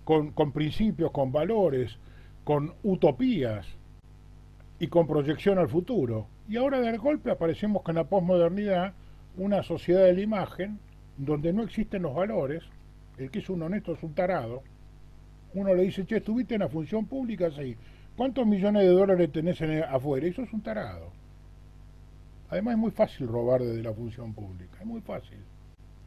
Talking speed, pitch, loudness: 165 wpm, 165 Hz, -28 LUFS